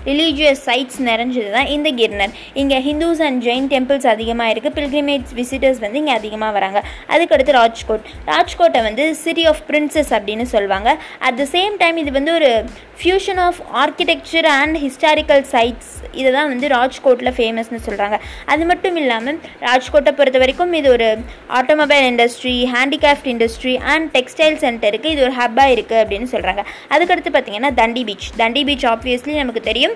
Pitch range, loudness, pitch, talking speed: 235-300 Hz, -15 LUFS, 265 Hz, 155 wpm